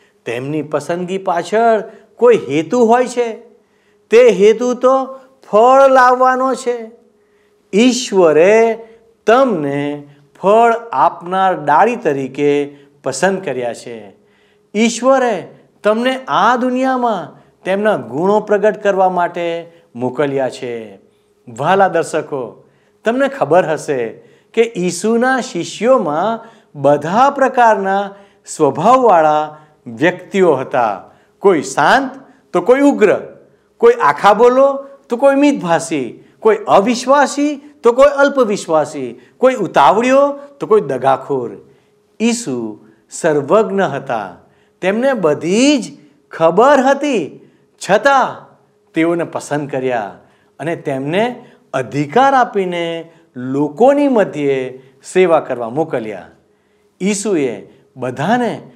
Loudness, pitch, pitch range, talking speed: -14 LUFS, 210 Hz, 155-245 Hz, 90 wpm